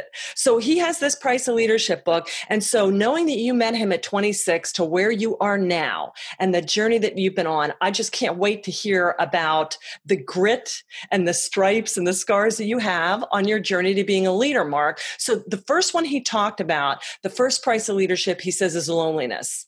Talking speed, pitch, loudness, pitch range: 215 wpm, 200 Hz, -21 LUFS, 180-225 Hz